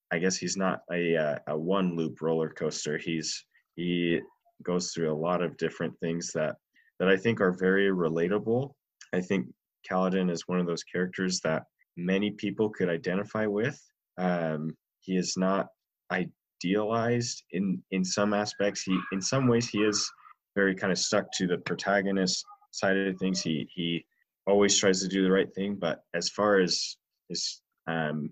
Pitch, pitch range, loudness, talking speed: 95 Hz, 85-100 Hz, -29 LUFS, 170 wpm